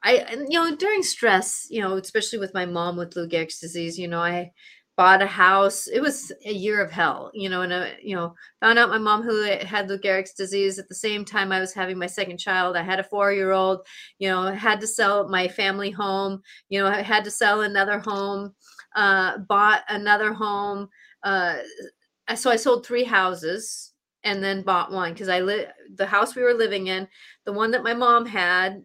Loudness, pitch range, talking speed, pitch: -22 LUFS, 185-215 Hz, 210 wpm, 200 Hz